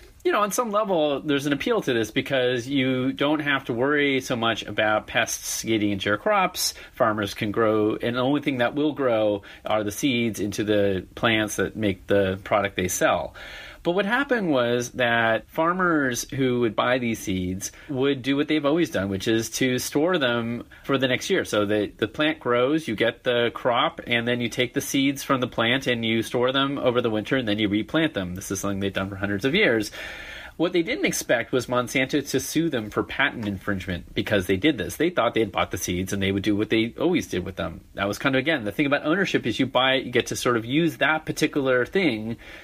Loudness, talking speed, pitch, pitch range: -24 LUFS, 235 wpm, 120 Hz, 105-140 Hz